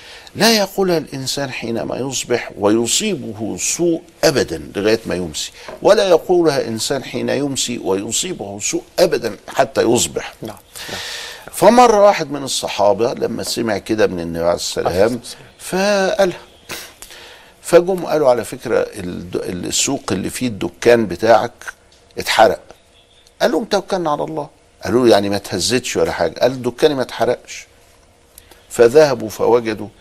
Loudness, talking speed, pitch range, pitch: -17 LUFS, 120 wpm, 110-175 Hz, 125 Hz